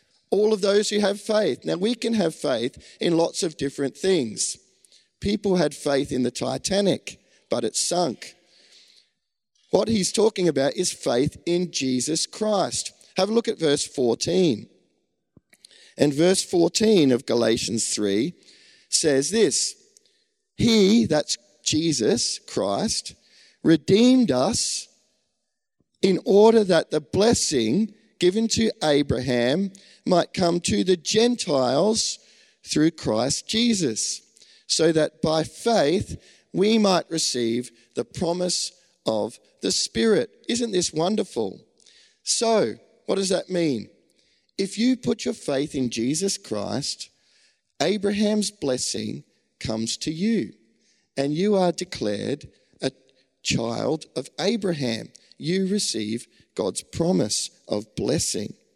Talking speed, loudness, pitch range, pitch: 120 wpm, -23 LUFS, 145-215 Hz, 180 Hz